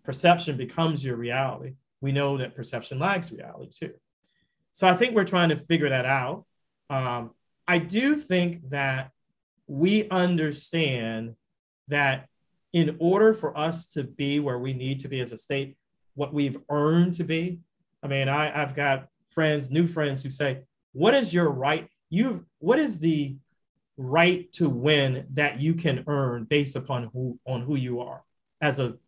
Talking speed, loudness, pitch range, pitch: 165 wpm, -26 LUFS, 135-170 Hz, 145 Hz